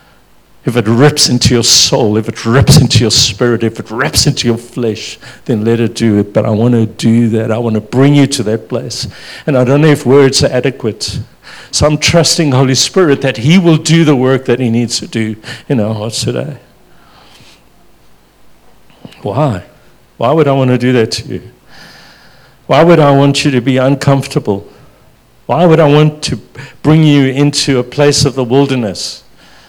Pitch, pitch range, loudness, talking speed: 125 Hz, 115-140 Hz, -10 LUFS, 195 wpm